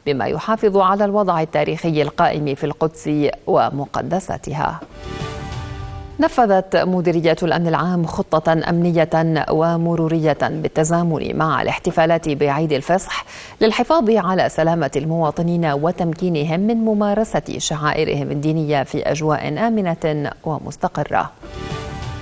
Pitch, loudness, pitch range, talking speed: 165 Hz, -19 LUFS, 155-180 Hz, 90 wpm